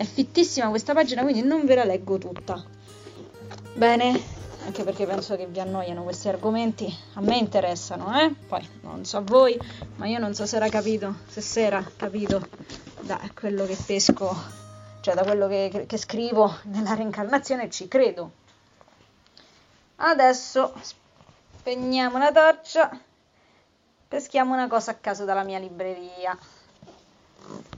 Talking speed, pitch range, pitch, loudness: 140 wpm, 195-255 Hz, 210 Hz, -24 LUFS